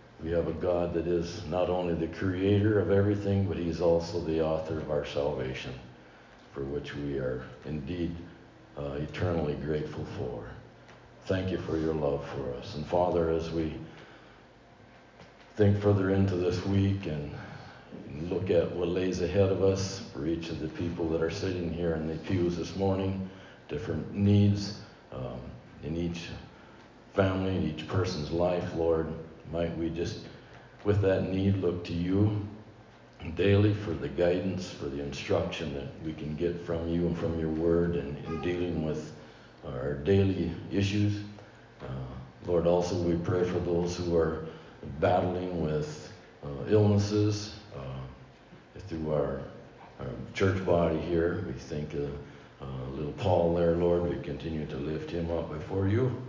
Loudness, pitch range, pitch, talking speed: -30 LUFS, 80-95 Hz, 85 Hz, 155 wpm